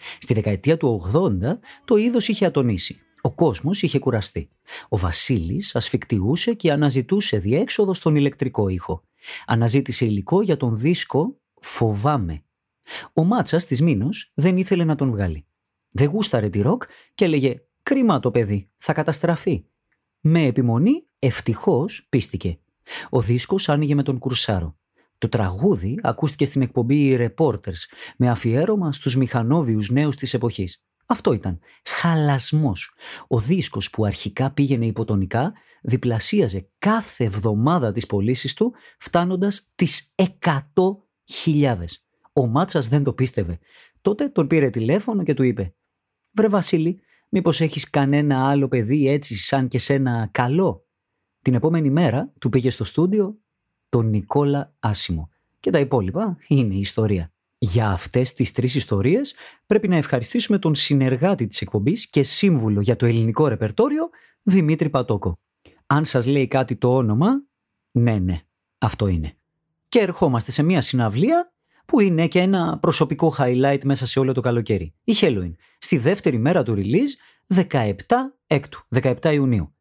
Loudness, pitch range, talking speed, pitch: -21 LUFS, 115-165 Hz, 140 wpm, 135 Hz